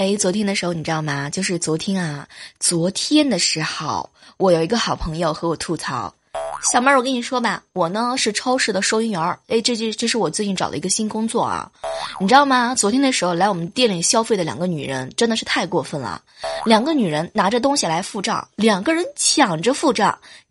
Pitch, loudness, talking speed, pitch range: 200 Hz, -19 LUFS, 325 characters per minute, 170-235 Hz